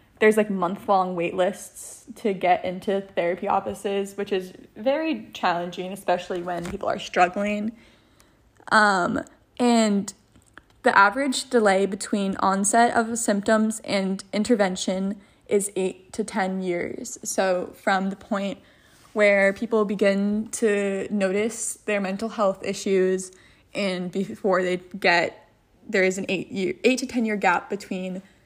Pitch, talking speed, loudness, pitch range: 200 Hz, 135 wpm, -24 LUFS, 190-215 Hz